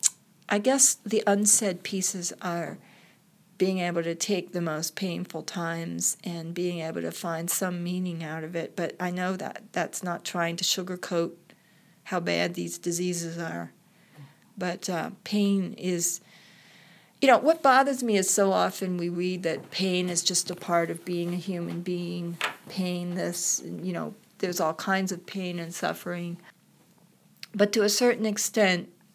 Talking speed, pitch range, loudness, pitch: 165 wpm, 170-195 Hz, -27 LUFS, 180 Hz